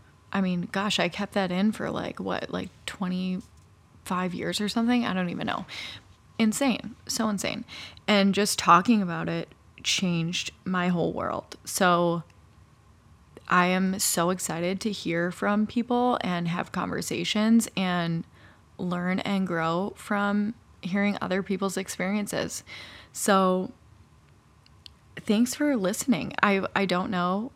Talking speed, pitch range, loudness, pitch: 130 wpm, 175-205 Hz, -27 LUFS, 185 Hz